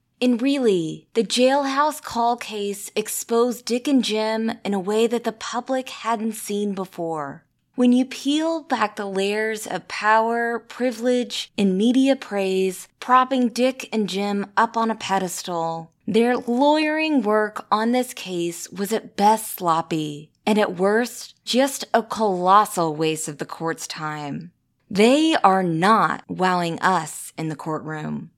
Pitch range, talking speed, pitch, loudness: 185-245 Hz, 145 wpm, 215 Hz, -22 LUFS